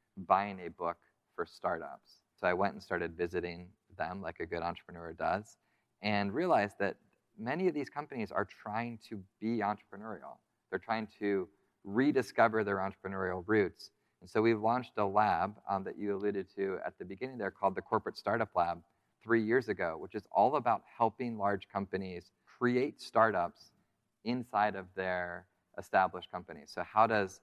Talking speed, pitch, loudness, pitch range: 165 wpm, 100 Hz, -34 LUFS, 90-110 Hz